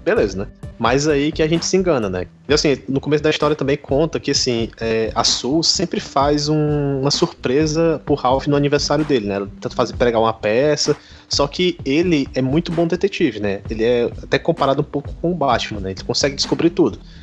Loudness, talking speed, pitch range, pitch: -18 LUFS, 215 wpm, 115-155 Hz, 140 Hz